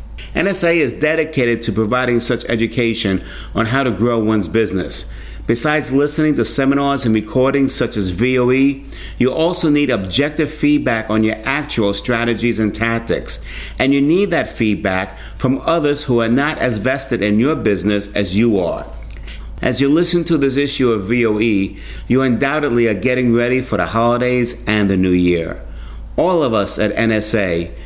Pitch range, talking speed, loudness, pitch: 105-135 Hz, 165 wpm, -16 LUFS, 115 Hz